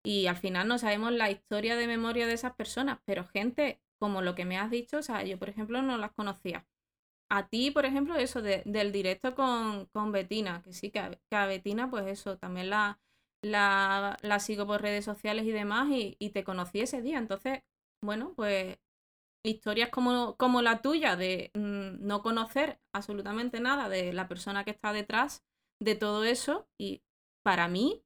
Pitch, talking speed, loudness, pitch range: 210 Hz, 190 wpm, -32 LUFS, 200-240 Hz